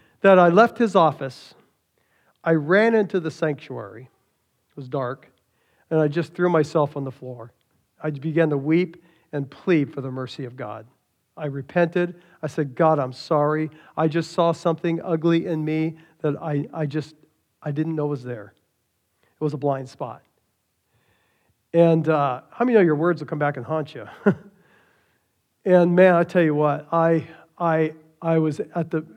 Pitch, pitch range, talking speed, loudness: 155 Hz, 140-170 Hz, 175 wpm, -22 LUFS